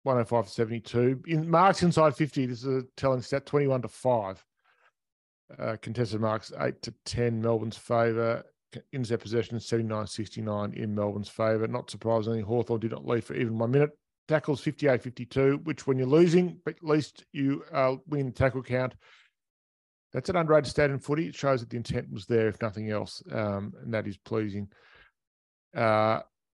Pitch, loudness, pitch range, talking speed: 120 Hz, -28 LUFS, 110-140 Hz, 175 wpm